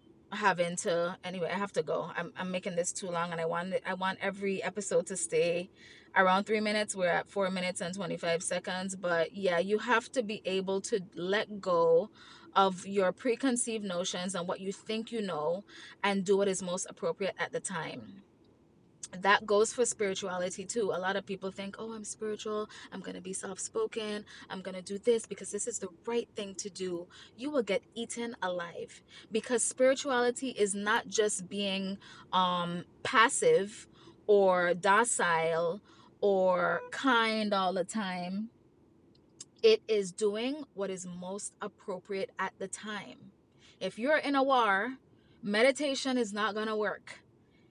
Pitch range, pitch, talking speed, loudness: 185-225 Hz, 200 Hz, 170 wpm, -31 LUFS